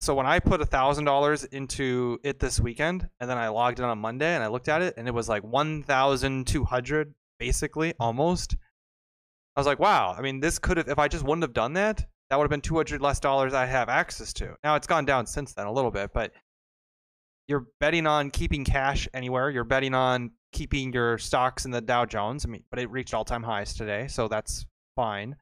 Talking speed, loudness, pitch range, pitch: 220 wpm, -27 LUFS, 120-150 Hz, 130 Hz